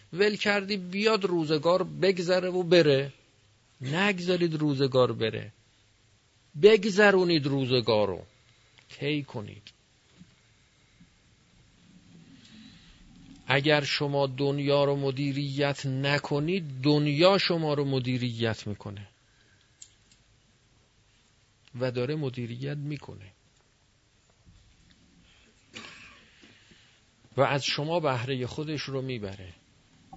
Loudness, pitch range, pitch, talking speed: -26 LUFS, 110-150 Hz, 130 Hz, 75 wpm